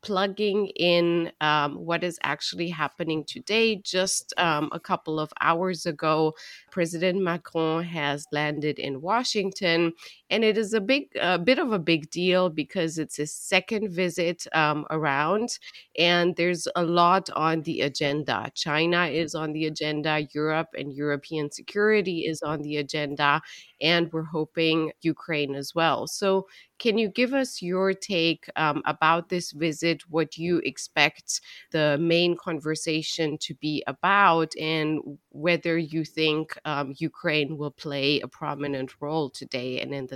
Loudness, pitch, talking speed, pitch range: -25 LUFS, 165 Hz, 150 wpm, 150-180 Hz